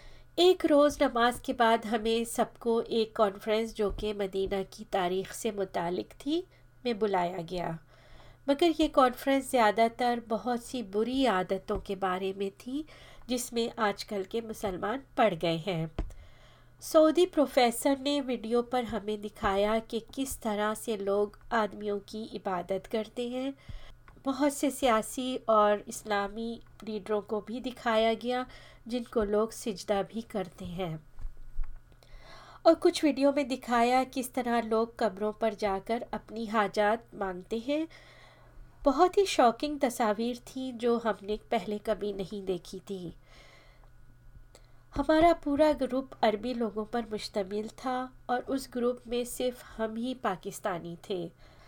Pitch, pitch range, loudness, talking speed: 225 Hz, 205-250 Hz, -30 LUFS, 135 wpm